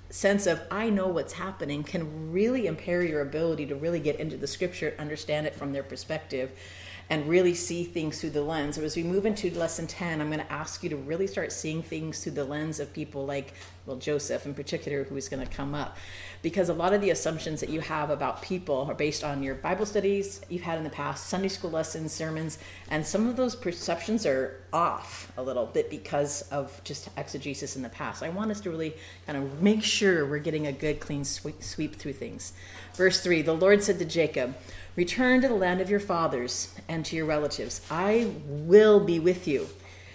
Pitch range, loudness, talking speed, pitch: 145-180 Hz, -29 LUFS, 215 wpm, 160 Hz